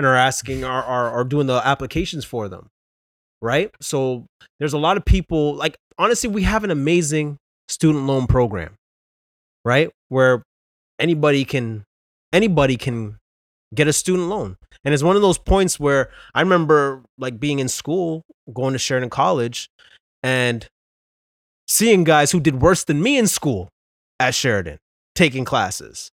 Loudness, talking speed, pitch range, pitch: -19 LUFS, 155 wpm, 120-160 Hz, 135 Hz